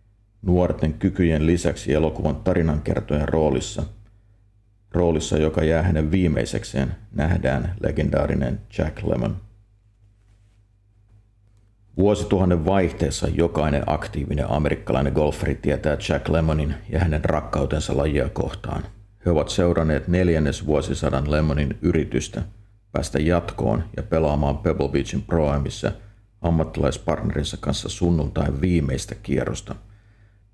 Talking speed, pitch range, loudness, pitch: 95 wpm, 75-100 Hz, -23 LUFS, 85 Hz